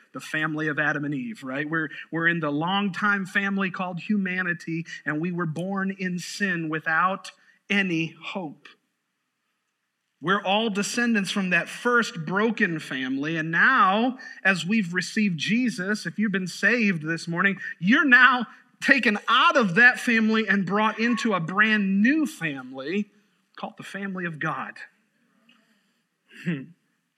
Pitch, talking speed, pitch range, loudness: 195 Hz, 140 wpm, 170-220 Hz, -23 LUFS